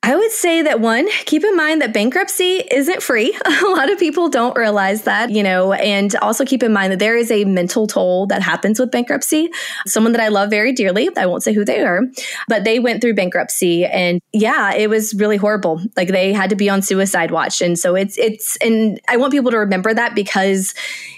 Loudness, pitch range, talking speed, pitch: -15 LUFS, 195-260 Hz, 225 wpm, 220 Hz